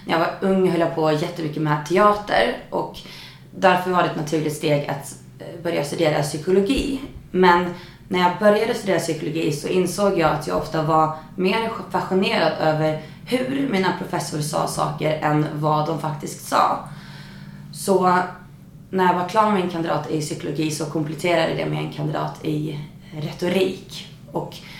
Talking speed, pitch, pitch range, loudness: 160 wpm, 165 Hz, 155-185 Hz, -21 LUFS